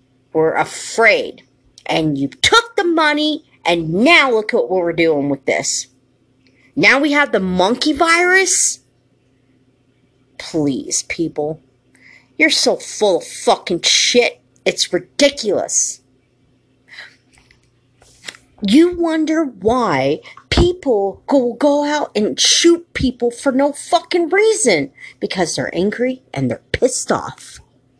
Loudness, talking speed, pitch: -15 LUFS, 115 wpm, 215 Hz